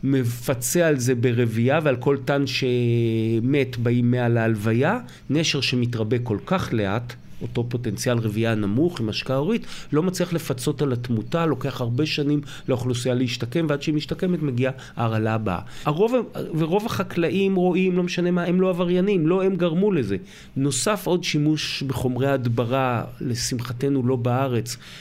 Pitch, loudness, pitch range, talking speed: 135 Hz, -23 LUFS, 120-165 Hz, 145 wpm